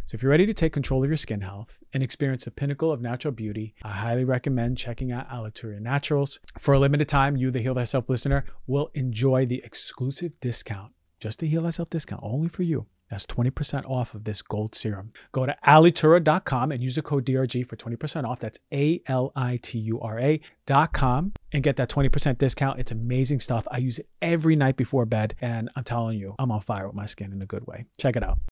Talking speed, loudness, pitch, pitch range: 205 wpm, -26 LUFS, 130 Hz, 115-145 Hz